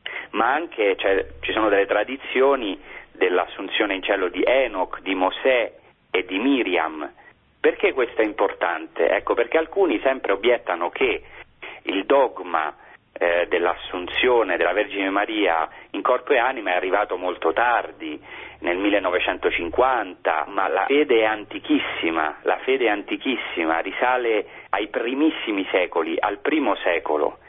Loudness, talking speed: -22 LUFS, 130 wpm